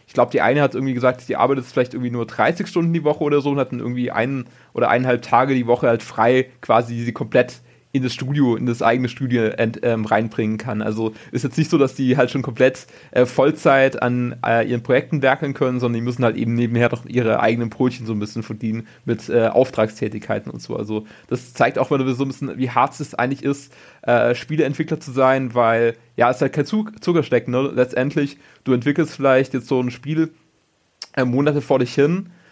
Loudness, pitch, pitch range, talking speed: -20 LUFS, 125 Hz, 115-140 Hz, 220 wpm